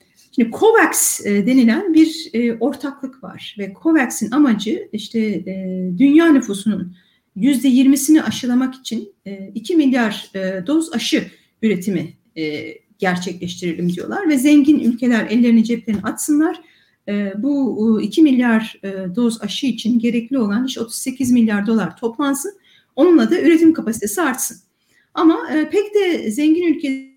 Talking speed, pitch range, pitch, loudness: 115 wpm, 205-295 Hz, 235 Hz, -17 LUFS